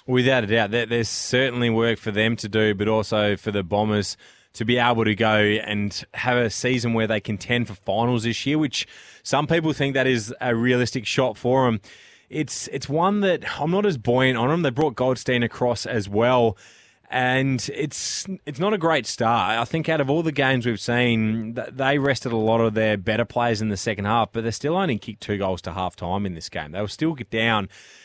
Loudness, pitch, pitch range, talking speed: -22 LUFS, 120 Hz, 110-130 Hz, 220 wpm